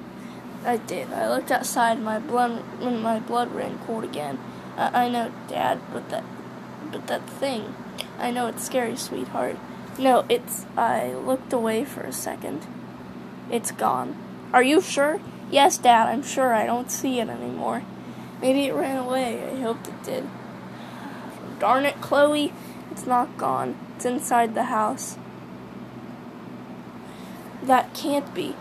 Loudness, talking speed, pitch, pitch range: -24 LUFS, 145 wpm, 245 Hz, 230-265 Hz